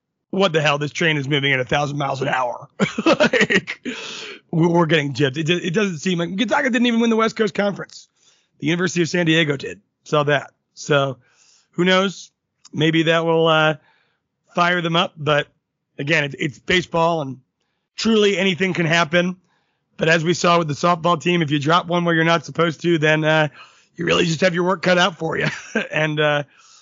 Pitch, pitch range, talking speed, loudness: 170 Hz, 150-180 Hz, 200 wpm, -19 LUFS